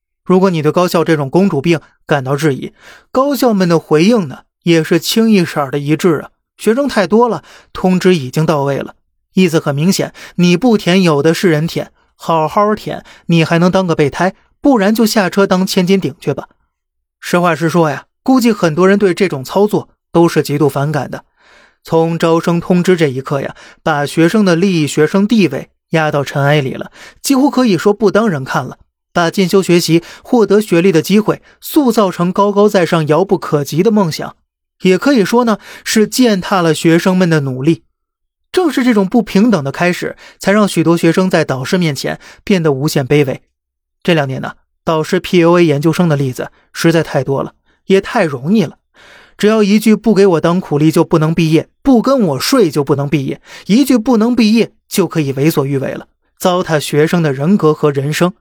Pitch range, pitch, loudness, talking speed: 155-200 Hz, 175 Hz, -13 LUFS, 280 characters per minute